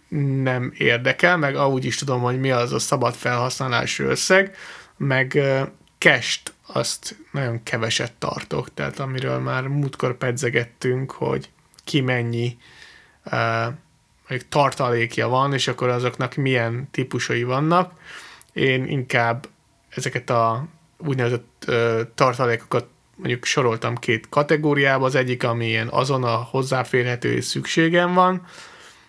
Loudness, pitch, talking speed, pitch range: -21 LUFS, 130 Hz, 110 wpm, 120-140 Hz